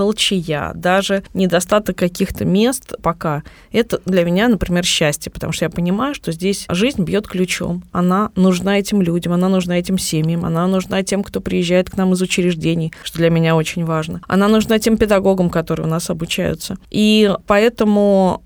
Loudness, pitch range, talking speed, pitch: -17 LUFS, 170-200 Hz, 170 wpm, 185 Hz